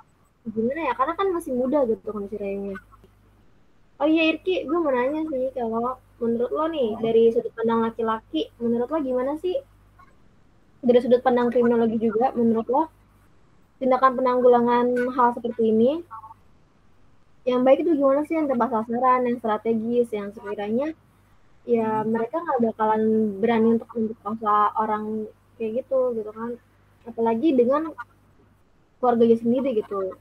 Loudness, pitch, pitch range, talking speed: -23 LUFS, 240 Hz, 225-260 Hz, 135 wpm